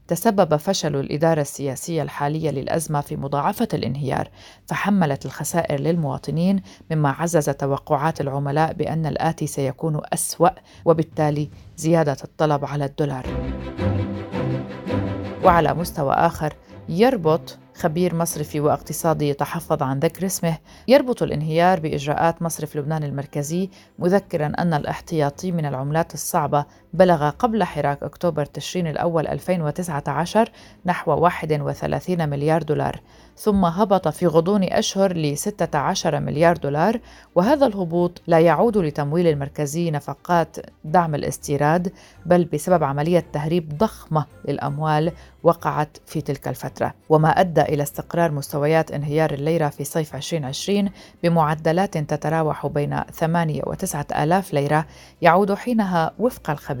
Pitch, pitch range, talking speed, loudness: 160 Hz, 145-175 Hz, 115 wpm, -22 LUFS